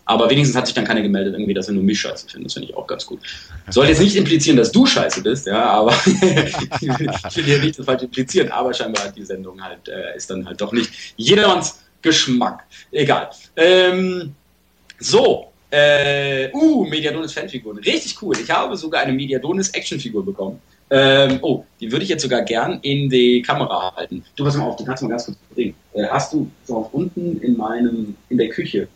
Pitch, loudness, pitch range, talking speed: 135 Hz, -17 LUFS, 115-160 Hz, 195 wpm